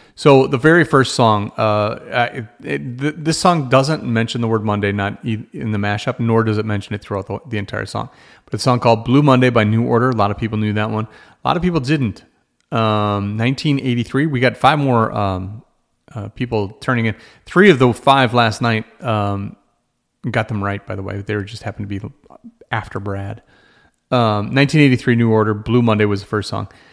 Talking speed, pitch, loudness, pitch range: 215 wpm, 115 Hz, -17 LUFS, 105-130 Hz